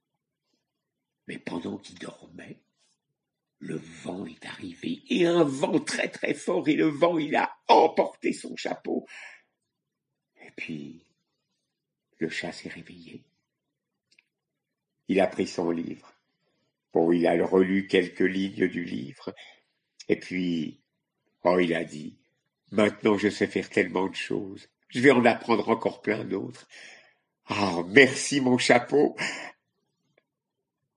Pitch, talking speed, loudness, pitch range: 100 Hz, 130 wpm, -25 LUFS, 85-135 Hz